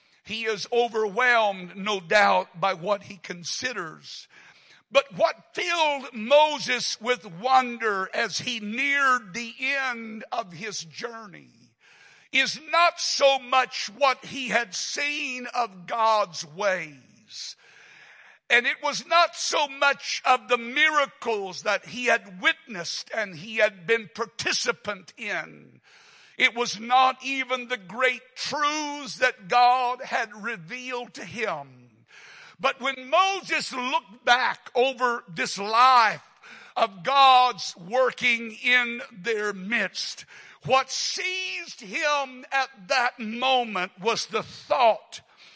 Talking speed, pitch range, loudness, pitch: 115 wpm, 215-270 Hz, -24 LUFS, 245 Hz